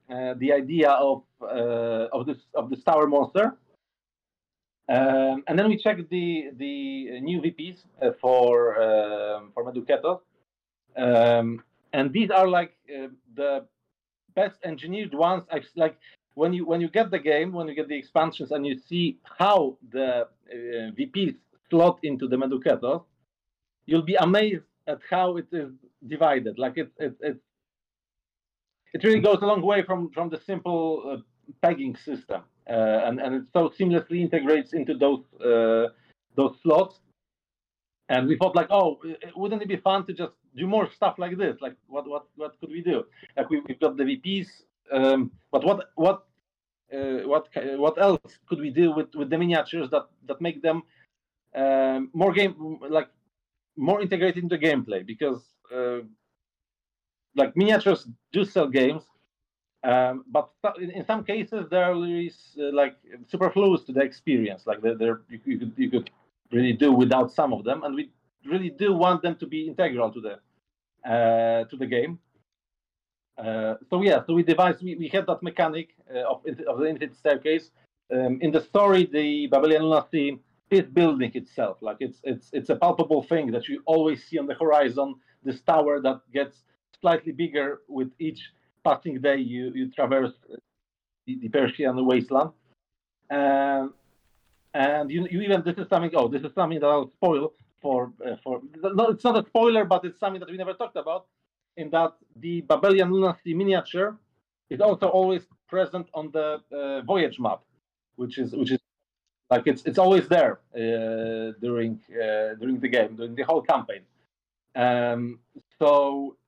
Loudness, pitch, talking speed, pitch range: -25 LUFS, 155 Hz, 170 wpm, 130-180 Hz